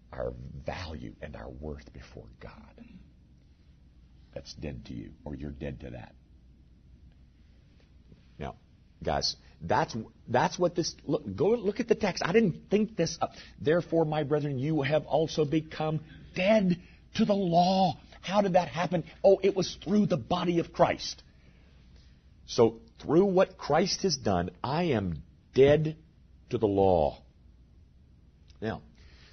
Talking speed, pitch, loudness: 140 wpm, 100 Hz, -28 LUFS